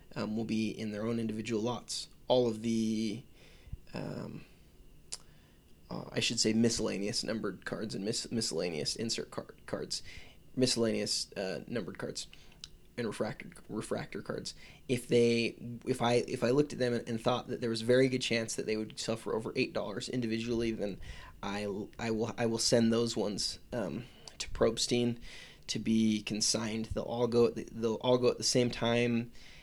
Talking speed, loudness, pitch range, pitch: 175 wpm, -33 LUFS, 110-120 Hz, 115 Hz